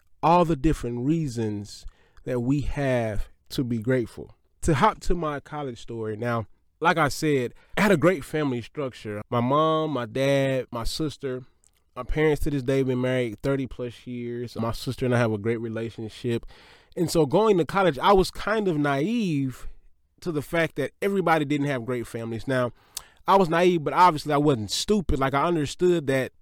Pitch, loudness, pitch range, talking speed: 135 Hz, -25 LUFS, 120-155 Hz, 190 wpm